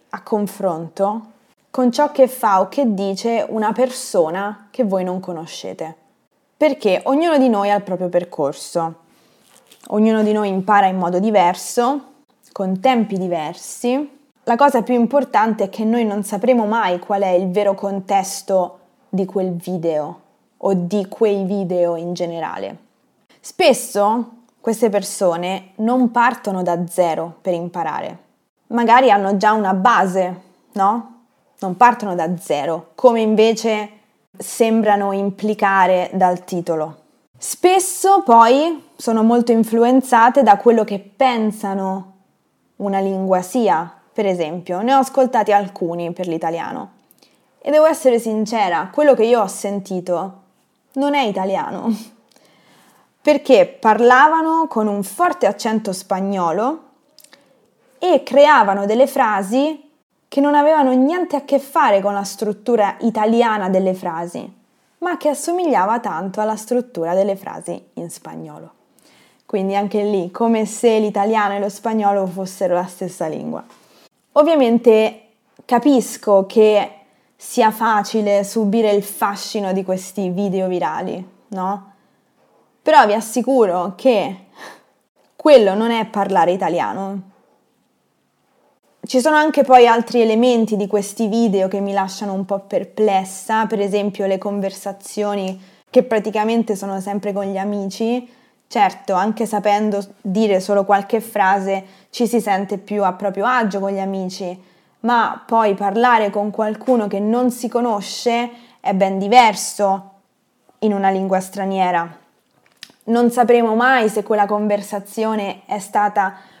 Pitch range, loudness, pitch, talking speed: 195-240 Hz, -17 LUFS, 210 Hz, 130 wpm